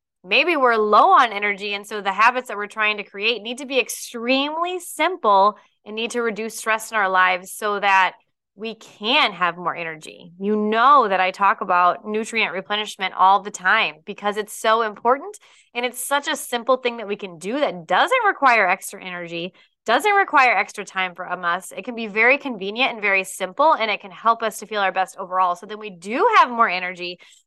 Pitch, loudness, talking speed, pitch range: 210 Hz, -19 LUFS, 210 wpm, 190-240 Hz